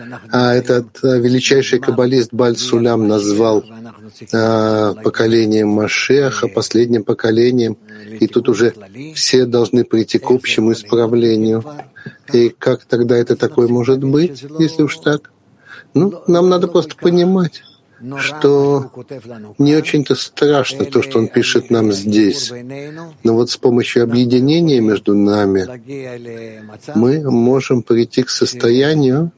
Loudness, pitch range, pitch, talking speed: -14 LUFS, 115-140 Hz, 120 Hz, 120 wpm